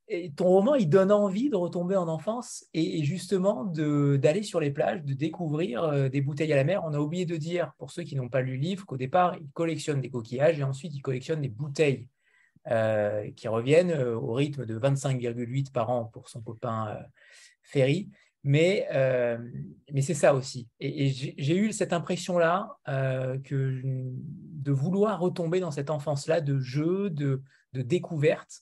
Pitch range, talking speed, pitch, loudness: 130-175 Hz, 185 wpm, 150 Hz, -28 LUFS